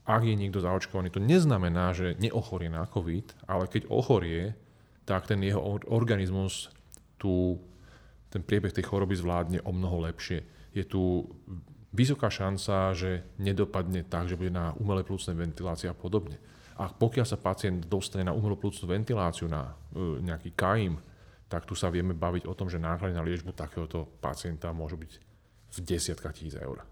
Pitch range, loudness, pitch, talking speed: 85-100 Hz, -31 LUFS, 95 Hz, 160 wpm